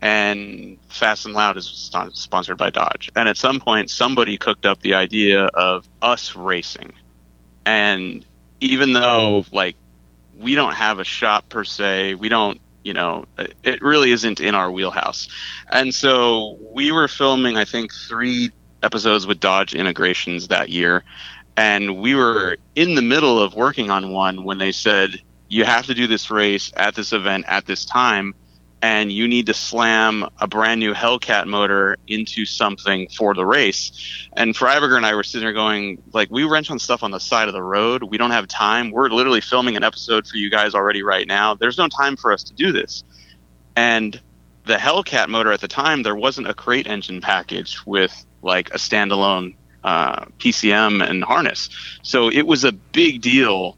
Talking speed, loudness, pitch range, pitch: 185 wpm, -18 LUFS, 95-115 Hz, 105 Hz